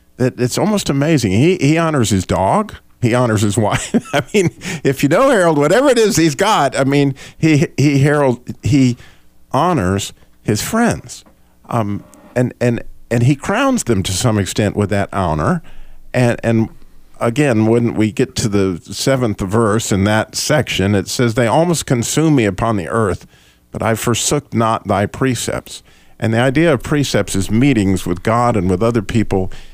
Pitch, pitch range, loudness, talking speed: 120 Hz, 105-140 Hz, -15 LUFS, 175 wpm